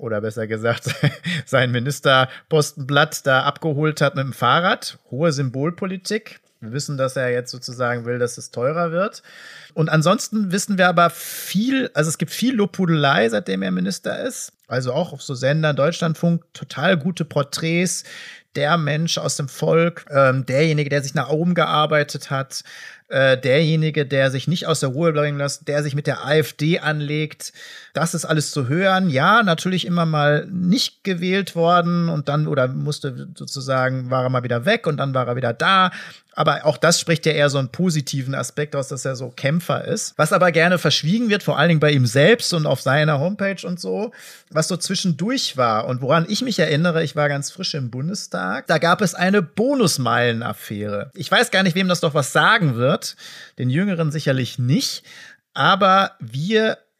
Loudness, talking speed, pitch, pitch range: -19 LUFS, 180 wpm, 155 Hz, 135-175 Hz